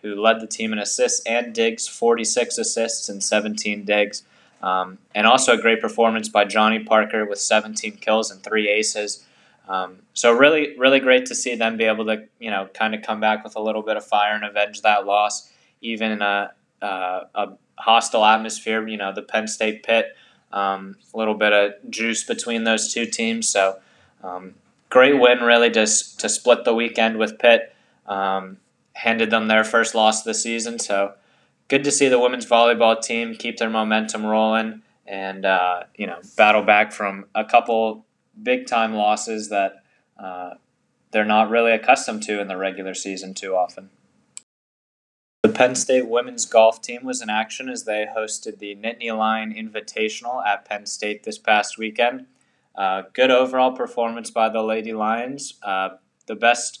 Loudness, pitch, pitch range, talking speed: -20 LUFS, 110 Hz, 105-115 Hz, 180 wpm